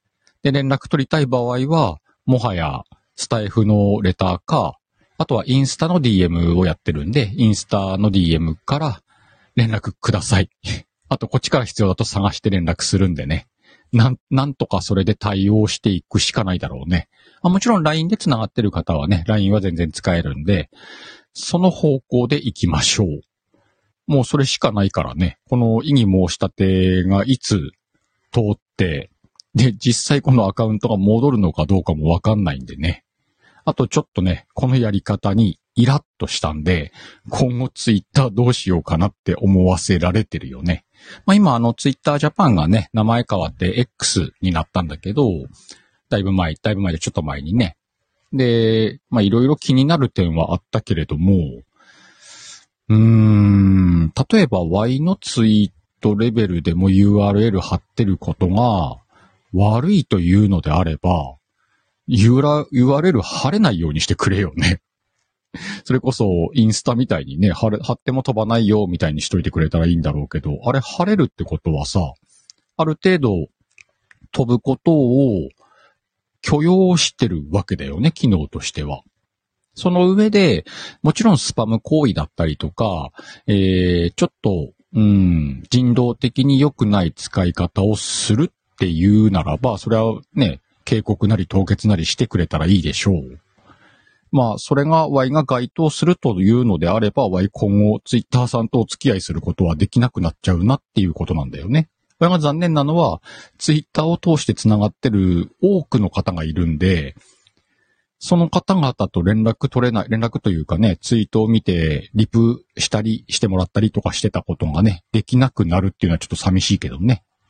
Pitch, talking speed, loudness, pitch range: 105 Hz, 340 characters per minute, -18 LUFS, 90-125 Hz